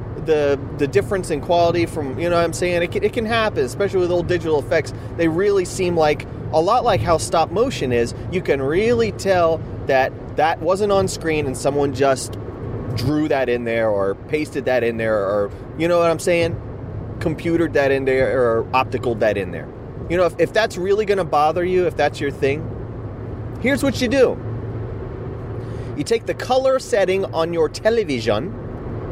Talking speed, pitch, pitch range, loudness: 195 wpm, 145 Hz, 120-175 Hz, -20 LUFS